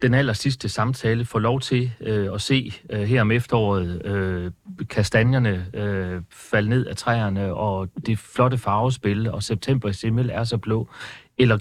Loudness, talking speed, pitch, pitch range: -23 LUFS, 170 wpm, 110 Hz, 100-125 Hz